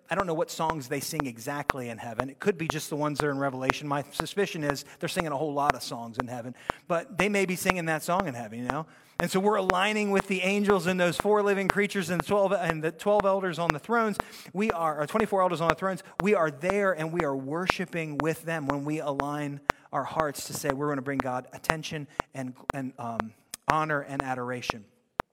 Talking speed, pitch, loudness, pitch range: 240 wpm, 160 Hz, -29 LUFS, 140-185 Hz